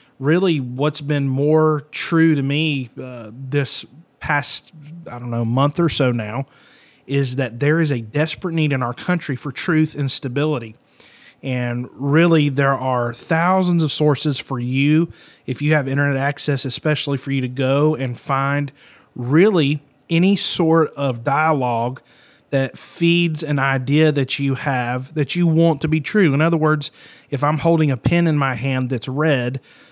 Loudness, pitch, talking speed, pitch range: -19 LUFS, 145 Hz, 165 wpm, 135-155 Hz